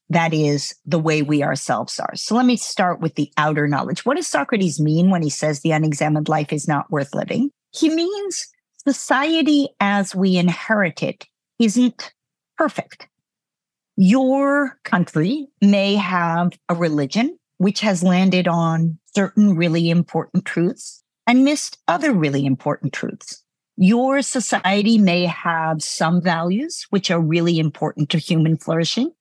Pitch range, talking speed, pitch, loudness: 160-230 Hz, 145 wpm, 180 Hz, -19 LUFS